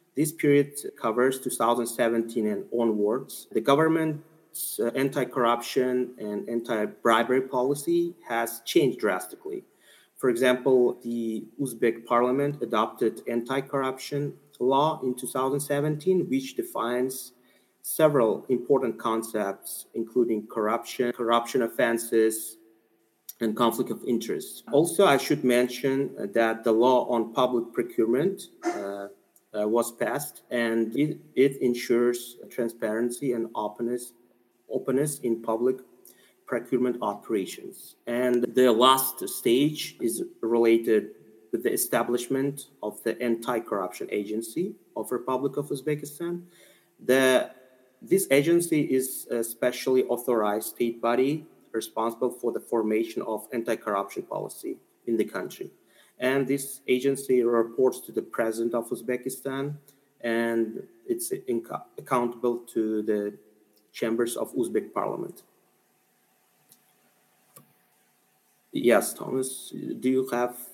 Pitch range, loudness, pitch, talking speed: 115-140 Hz, -27 LUFS, 125 Hz, 105 wpm